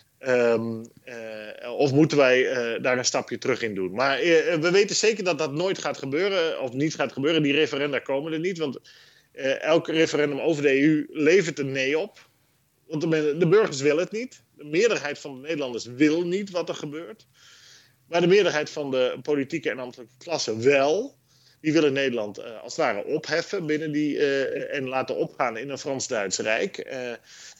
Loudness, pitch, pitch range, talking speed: -24 LUFS, 150 Hz, 135-170 Hz, 190 wpm